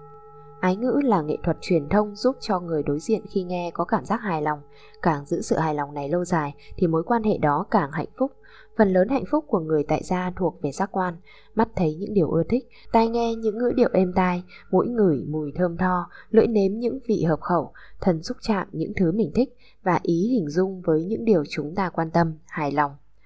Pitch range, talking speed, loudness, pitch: 160-220 Hz, 235 wpm, -24 LUFS, 185 Hz